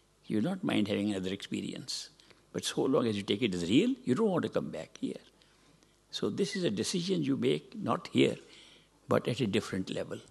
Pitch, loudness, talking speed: 115 Hz, -32 LUFS, 215 wpm